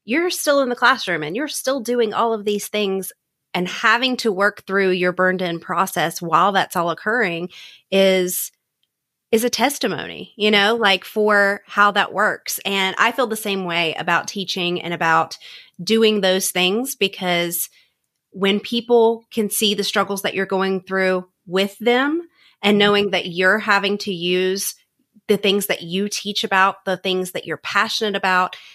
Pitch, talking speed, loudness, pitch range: 200 Hz, 170 wpm, -19 LUFS, 185-220 Hz